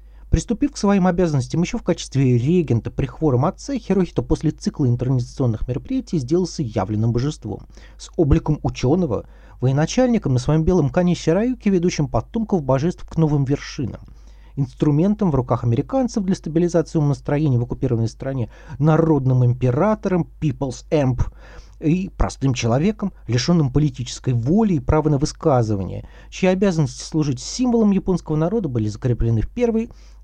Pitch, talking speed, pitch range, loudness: 150 Hz, 135 wpm, 125-180 Hz, -20 LUFS